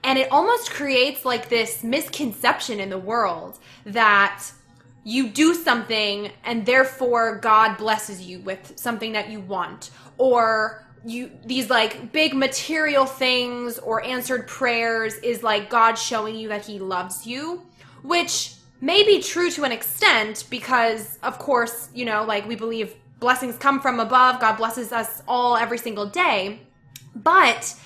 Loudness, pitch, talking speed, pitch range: -21 LUFS, 235 Hz, 150 wpm, 215-255 Hz